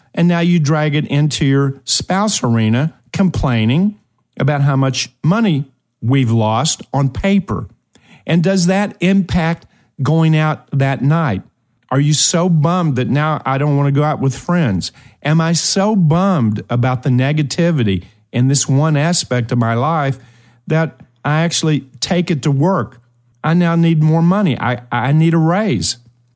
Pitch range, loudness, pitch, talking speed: 125-165 Hz, -15 LUFS, 145 Hz, 160 wpm